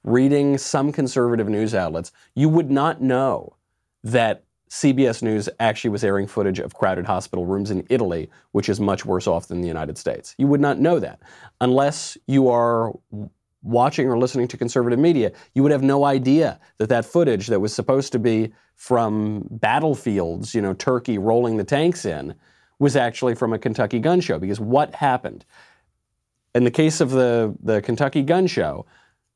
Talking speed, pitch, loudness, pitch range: 175 wpm, 120 Hz, -21 LUFS, 105-140 Hz